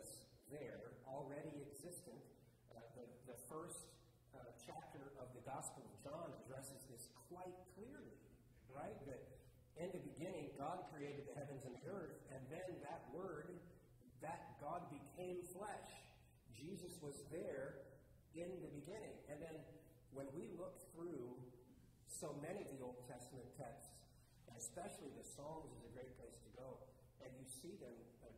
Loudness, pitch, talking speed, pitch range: -55 LUFS, 140 Hz, 150 wpm, 125-160 Hz